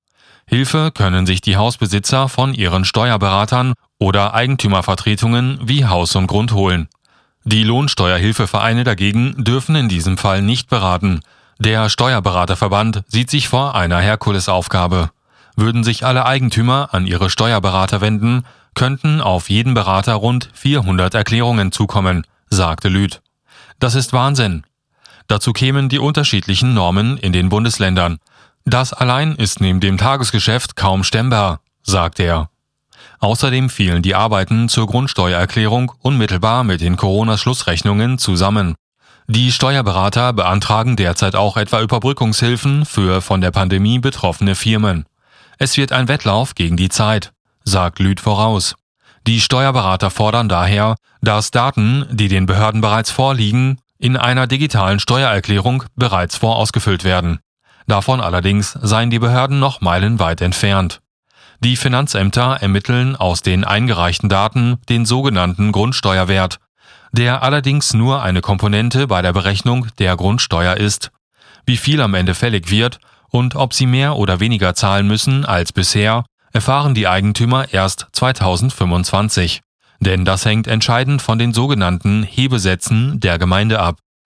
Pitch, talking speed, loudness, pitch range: 110 Hz, 130 wpm, -15 LUFS, 95-125 Hz